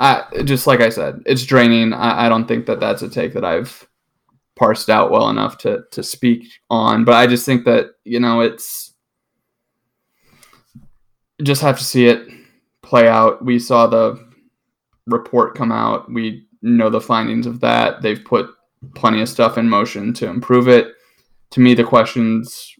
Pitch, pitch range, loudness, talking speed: 120 Hz, 115-125 Hz, -15 LUFS, 175 wpm